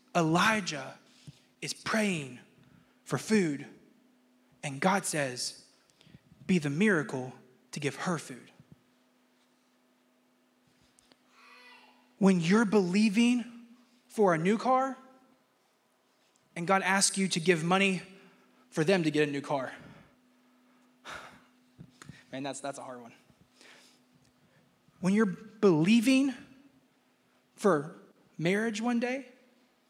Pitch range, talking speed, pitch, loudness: 155-240 Hz, 100 wpm, 195 Hz, -29 LUFS